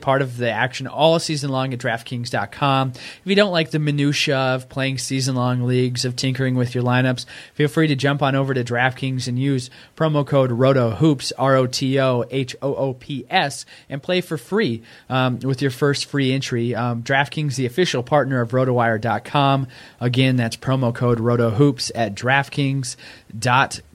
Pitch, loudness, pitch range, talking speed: 130 Hz, -20 LUFS, 125-140 Hz, 175 wpm